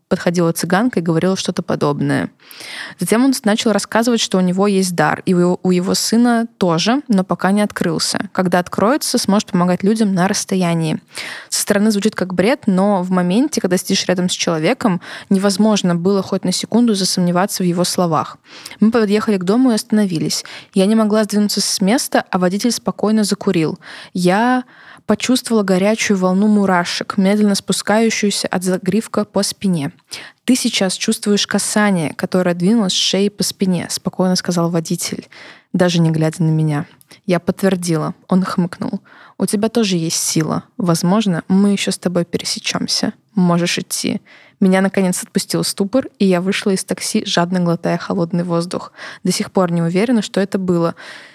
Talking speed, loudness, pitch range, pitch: 160 wpm, -16 LUFS, 180-215 Hz, 195 Hz